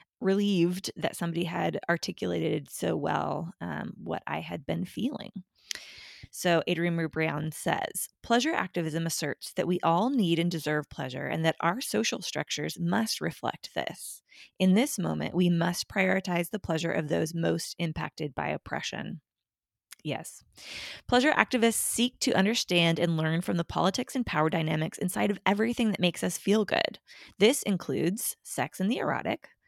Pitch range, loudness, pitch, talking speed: 165-205 Hz, -29 LUFS, 175 Hz, 155 wpm